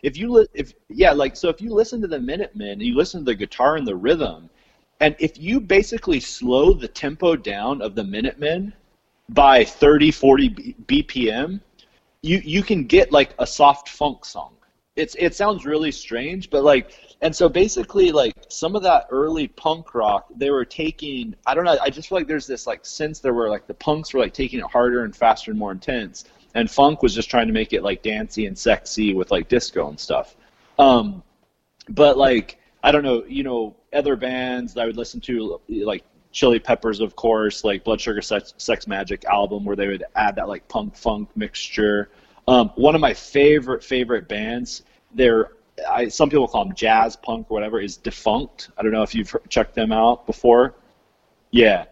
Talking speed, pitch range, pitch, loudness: 200 wpm, 115-195 Hz, 145 Hz, -20 LUFS